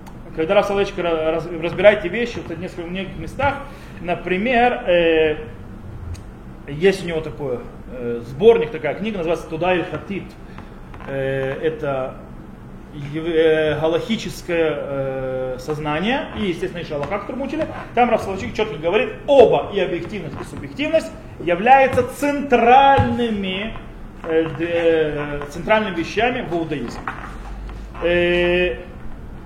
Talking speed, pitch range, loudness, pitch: 85 wpm, 155-210 Hz, -19 LUFS, 170 Hz